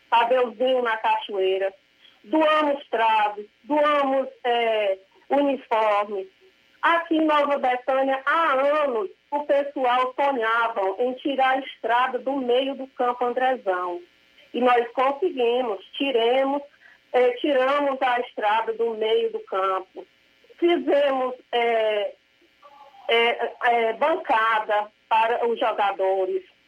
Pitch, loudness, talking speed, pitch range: 250 Hz, -23 LUFS, 105 wpm, 225-280 Hz